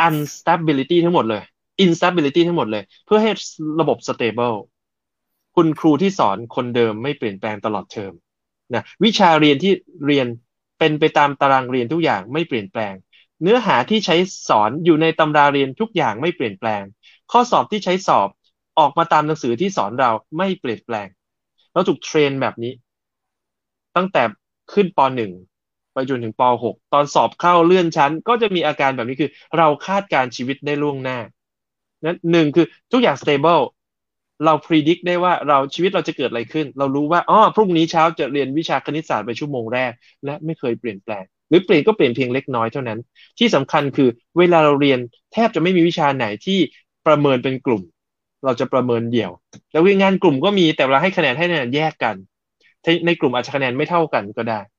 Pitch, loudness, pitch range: 150 Hz, -18 LUFS, 125-170 Hz